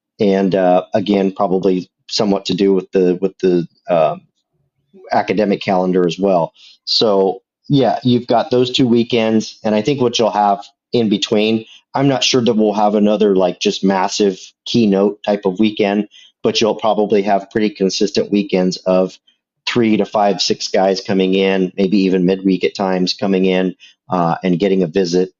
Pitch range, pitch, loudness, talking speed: 95-110 Hz, 100 Hz, -15 LUFS, 170 wpm